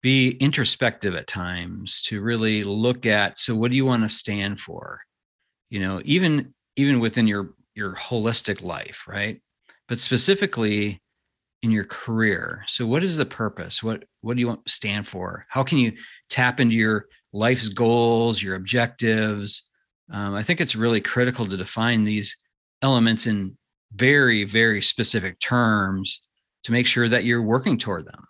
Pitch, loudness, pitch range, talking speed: 115 Hz, -21 LUFS, 105-125 Hz, 165 wpm